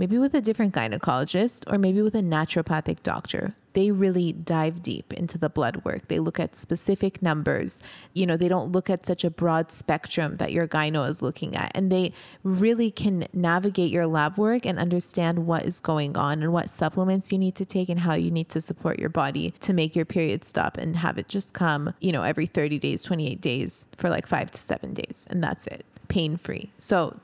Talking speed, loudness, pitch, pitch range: 215 wpm, -26 LUFS, 170 Hz, 160-190 Hz